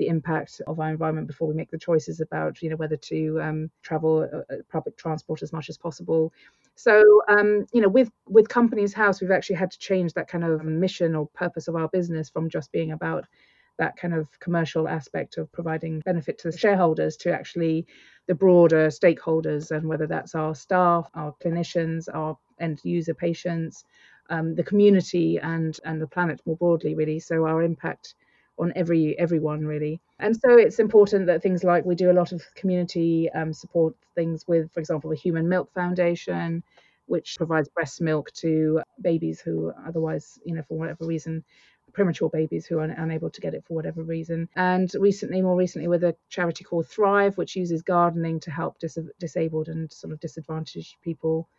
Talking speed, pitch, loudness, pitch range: 190 wpm, 165 Hz, -24 LUFS, 160-175 Hz